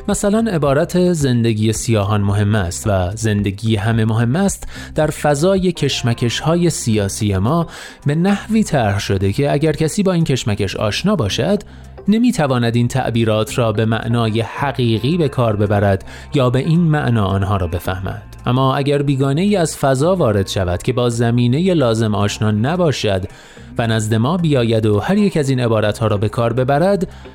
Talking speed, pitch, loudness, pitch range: 165 wpm, 120 Hz, -16 LUFS, 110-155 Hz